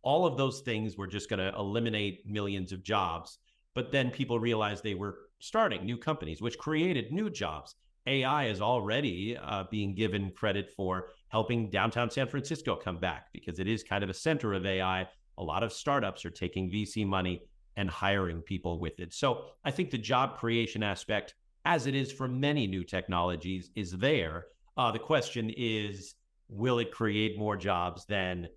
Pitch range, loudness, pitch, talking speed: 95-120 Hz, -32 LUFS, 105 Hz, 185 wpm